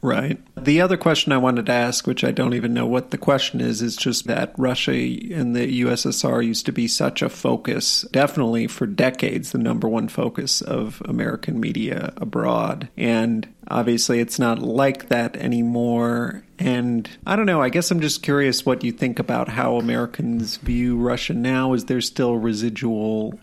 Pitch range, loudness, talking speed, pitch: 115-130 Hz, -21 LUFS, 180 wpm, 120 Hz